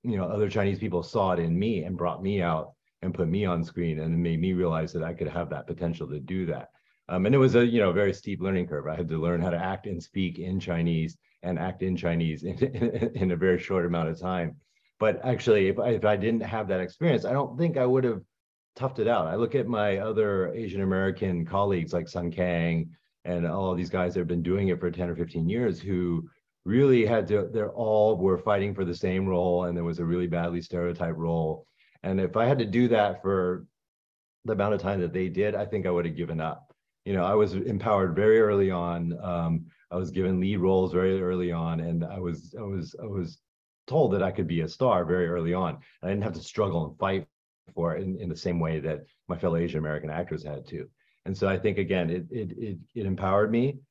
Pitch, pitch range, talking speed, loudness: 90 Hz, 85-100 Hz, 245 wpm, -27 LUFS